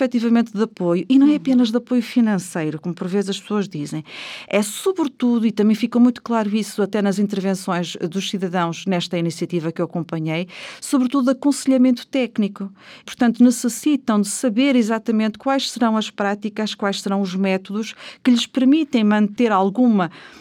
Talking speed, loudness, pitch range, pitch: 165 wpm, -19 LUFS, 195-245 Hz, 215 Hz